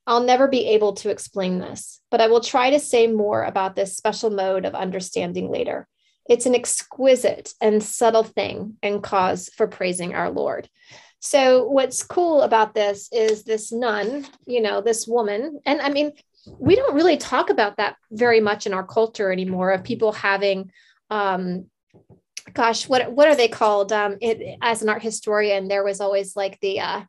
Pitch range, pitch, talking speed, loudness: 200-245 Hz, 220 Hz, 180 wpm, -21 LUFS